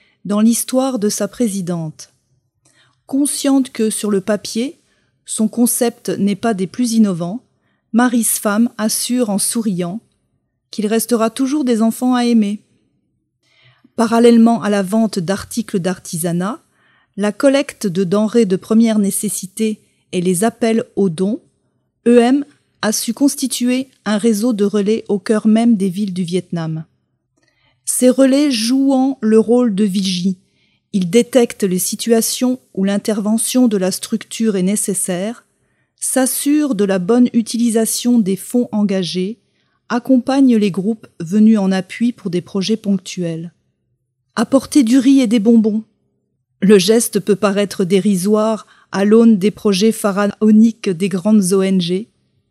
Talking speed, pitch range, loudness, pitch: 135 wpm, 195-240 Hz, -15 LUFS, 220 Hz